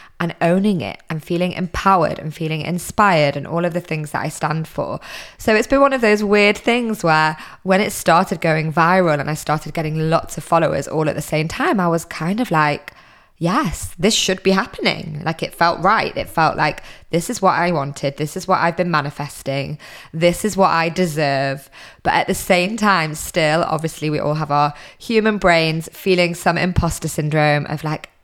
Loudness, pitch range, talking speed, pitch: -18 LUFS, 155-185 Hz, 205 wpm, 165 Hz